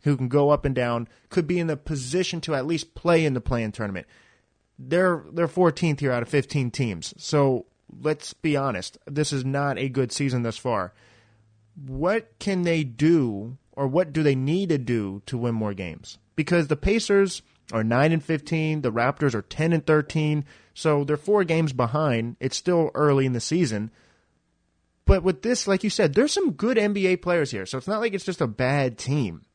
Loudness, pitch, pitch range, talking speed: -24 LUFS, 145 Hz, 120-170 Hz, 200 wpm